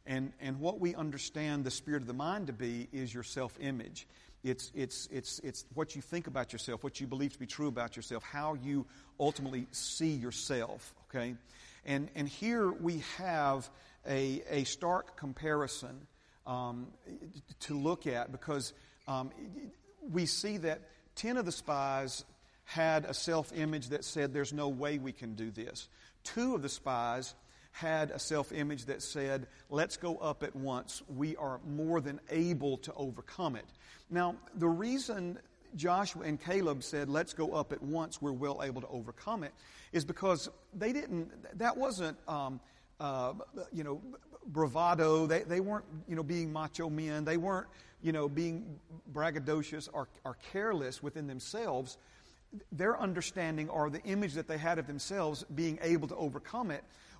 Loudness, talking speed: -37 LUFS, 165 wpm